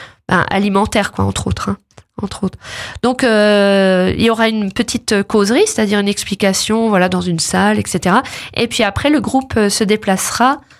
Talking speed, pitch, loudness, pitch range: 170 wpm, 210 Hz, -14 LUFS, 195-230 Hz